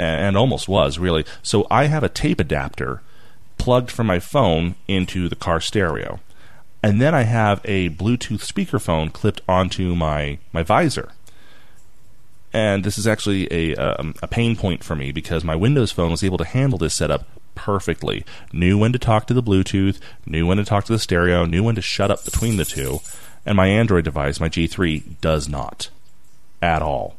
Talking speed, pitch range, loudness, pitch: 185 wpm, 85-110 Hz, -20 LUFS, 95 Hz